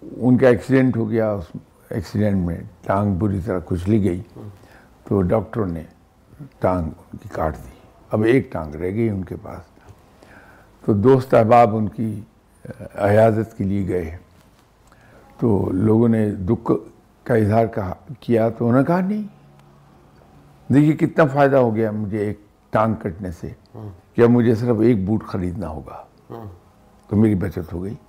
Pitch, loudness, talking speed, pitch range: 105 Hz, -19 LUFS, 155 wpm, 95-115 Hz